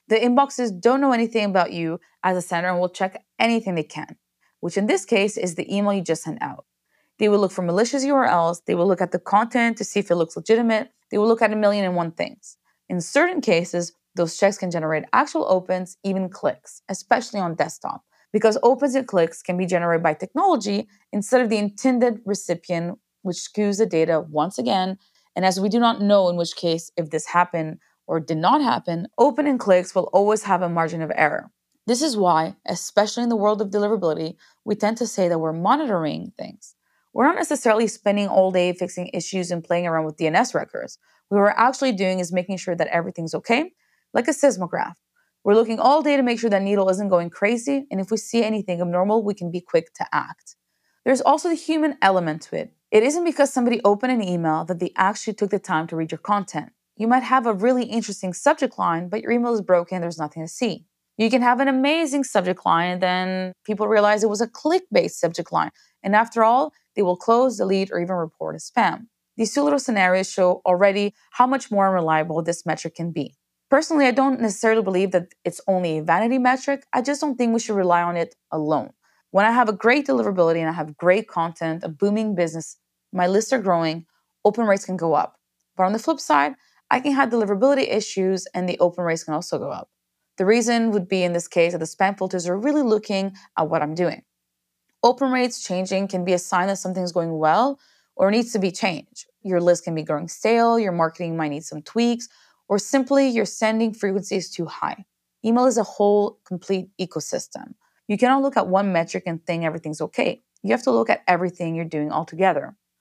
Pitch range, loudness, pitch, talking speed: 175-230 Hz, -21 LUFS, 195 Hz, 215 wpm